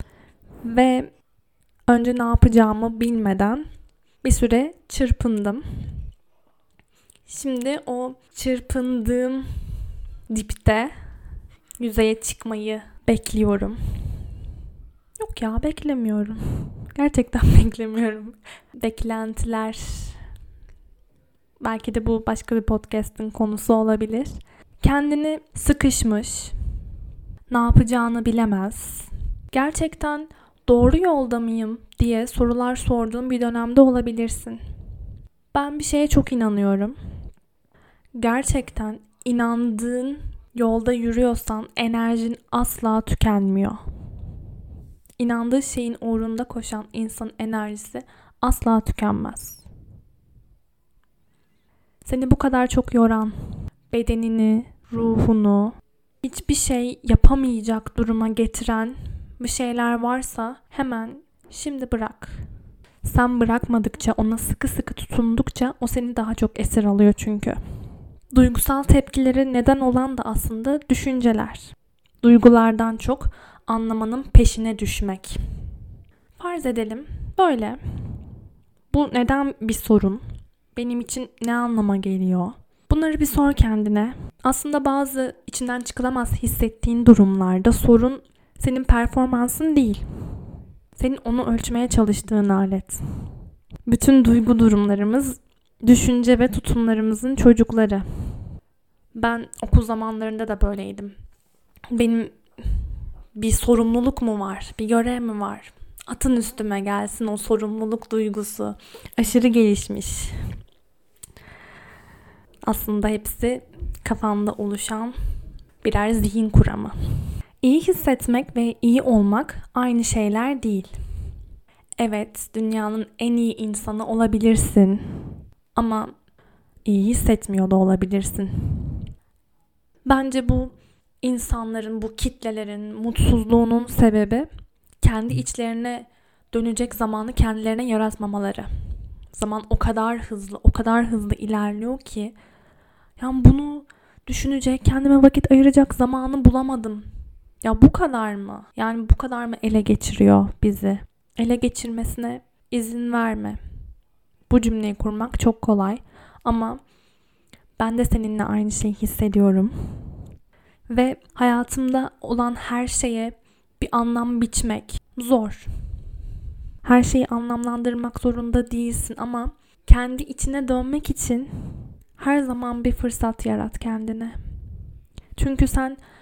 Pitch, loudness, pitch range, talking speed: 230 Hz, -21 LUFS, 215-245 Hz, 95 wpm